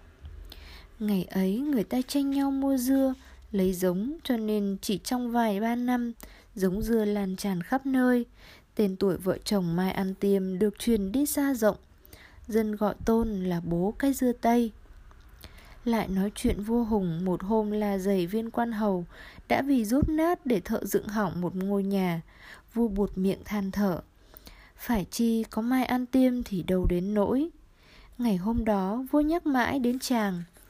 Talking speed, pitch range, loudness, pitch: 175 wpm, 195-245 Hz, -28 LUFS, 215 Hz